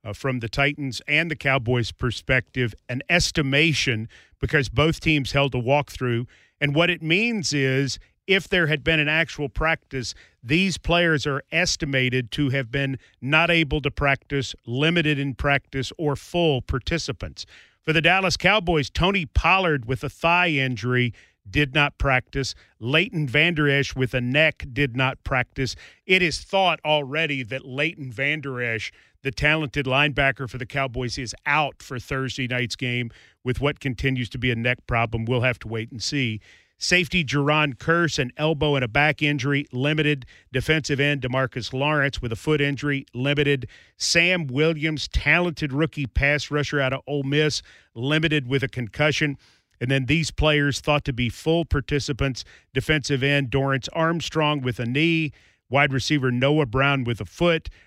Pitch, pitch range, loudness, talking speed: 140 Hz, 130-155 Hz, -22 LUFS, 165 wpm